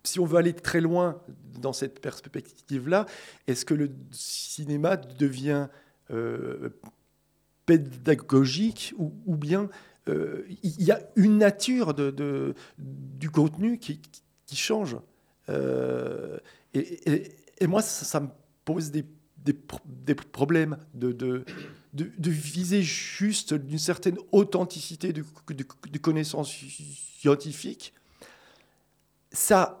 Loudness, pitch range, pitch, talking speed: -27 LUFS, 140-175 Hz, 150 Hz, 120 wpm